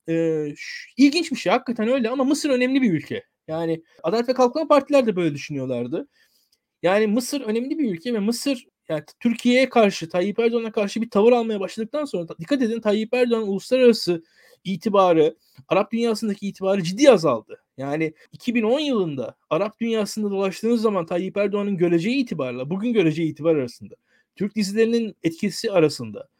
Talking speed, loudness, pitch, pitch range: 150 wpm, -22 LUFS, 215 Hz, 175-240 Hz